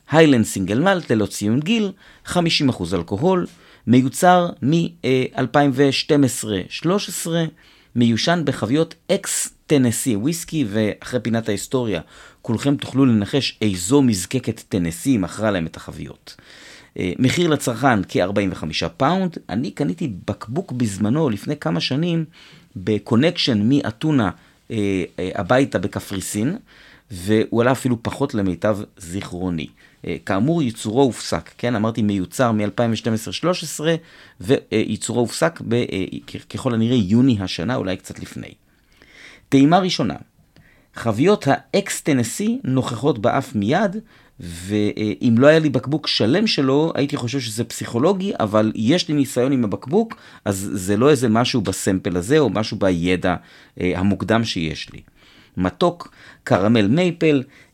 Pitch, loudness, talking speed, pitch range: 120 Hz, -20 LUFS, 115 wpm, 105-145 Hz